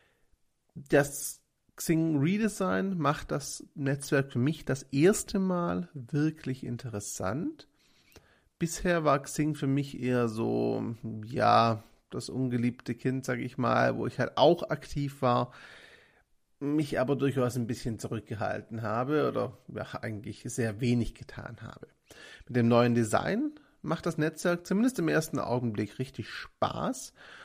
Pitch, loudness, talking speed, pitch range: 135 Hz, -30 LUFS, 130 wpm, 120-155 Hz